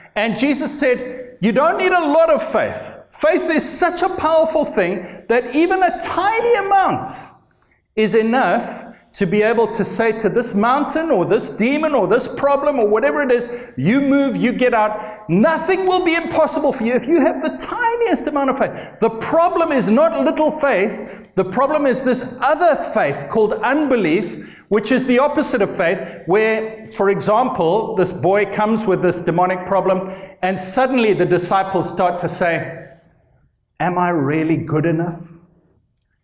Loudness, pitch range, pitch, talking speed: -17 LUFS, 190-300 Hz, 235 Hz, 170 wpm